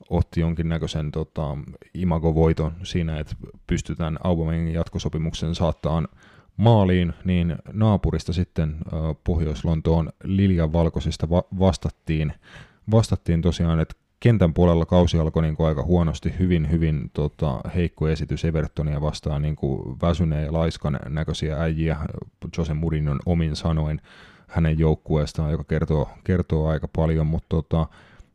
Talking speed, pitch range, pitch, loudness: 120 wpm, 80-85 Hz, 80 Hz, -23 LUFS